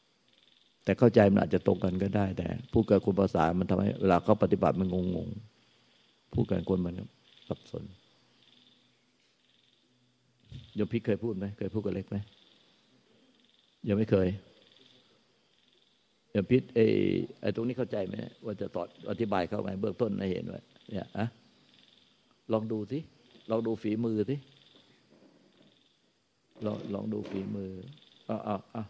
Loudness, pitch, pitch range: -31 LUFS, 105 Hz, 95-115 Hz